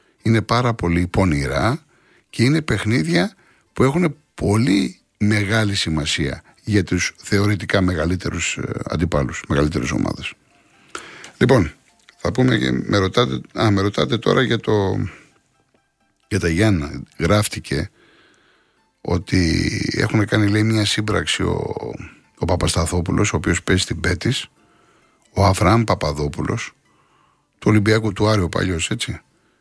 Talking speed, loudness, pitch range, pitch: 115 wpm, -19 LUFS, 85-110 Hz, 100 Hz